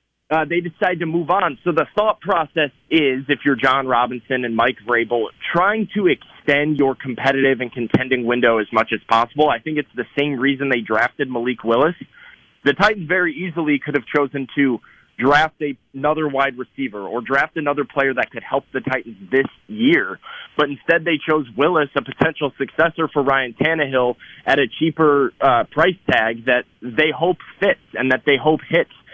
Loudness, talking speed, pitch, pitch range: -19 LUFS, 185 wpm, 140 Hz, 125-155 Hz